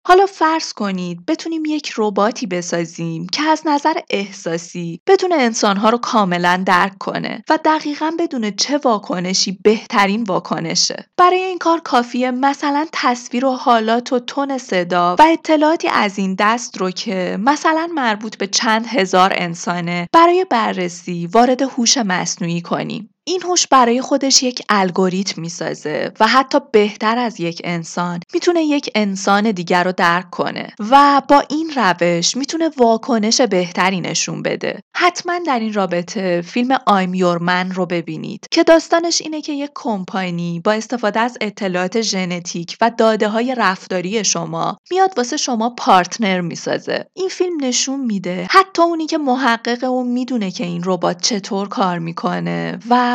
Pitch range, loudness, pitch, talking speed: 185-280 Hz, -16 LUFS, 225 Hz, 145 wpm